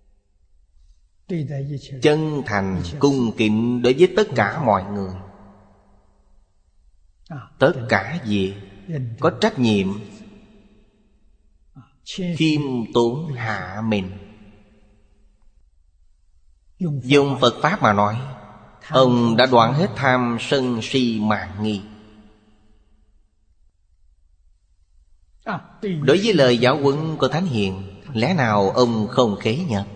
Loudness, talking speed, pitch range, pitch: -20 LUFS, 95 wpm, 95-130 Hz, 105 Hz